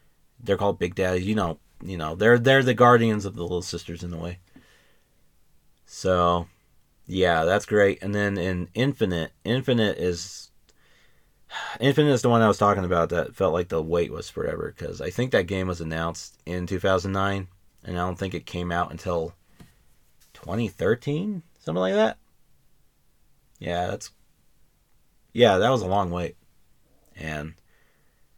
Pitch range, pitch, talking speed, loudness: 85-105 Hz, 95 Hz, 155 wpm, -24 LUFS